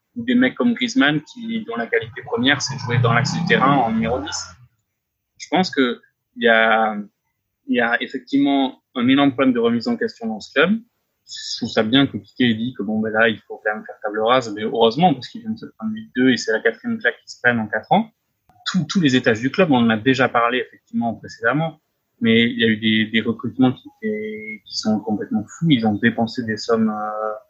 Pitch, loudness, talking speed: 130 Hz, -19 LUFS, 235 wpm